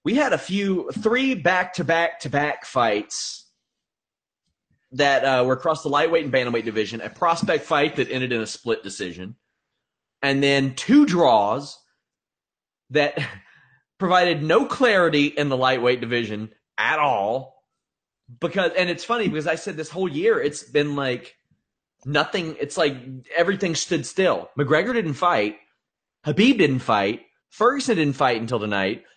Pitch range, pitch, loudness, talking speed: 130-185 Hz, 150 Hz, -22 LUFS, 140 wpm